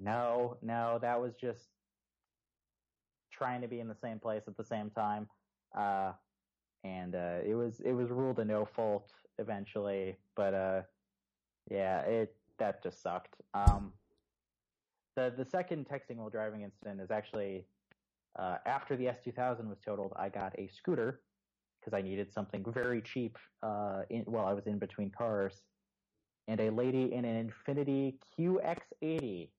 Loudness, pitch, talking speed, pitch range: -37 LUFS, 110 Hz, 160 wpm, 100-120 Hz